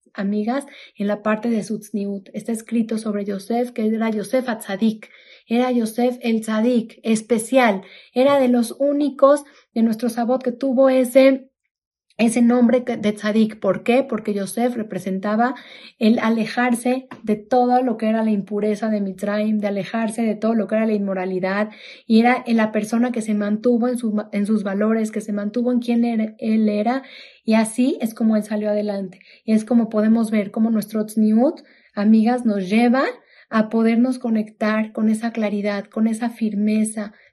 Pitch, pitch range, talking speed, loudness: 225 Hz, 210-245 Hz, 170 wpm, -20 LUFS